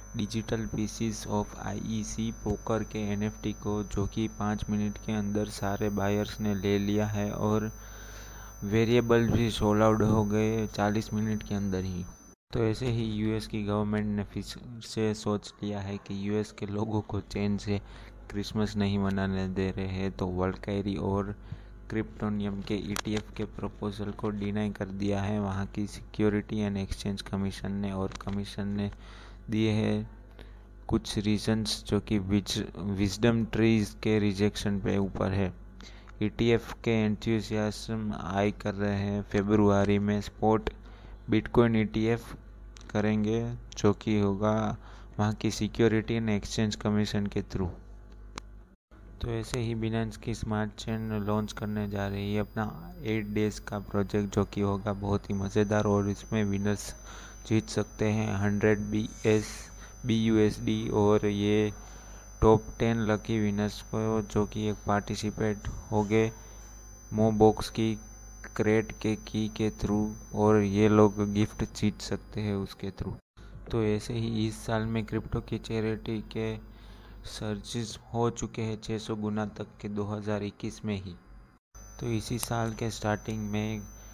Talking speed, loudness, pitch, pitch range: 150 wpm, -30 LUFS, 105 Hz, 100-110 Hz